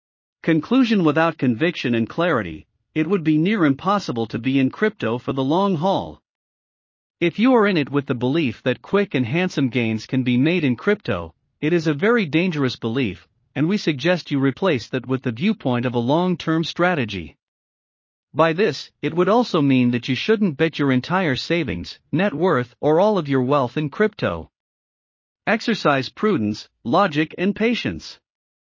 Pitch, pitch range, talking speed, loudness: 150 Hz, 125-185 Hz, 170 wpm, -20 LUFS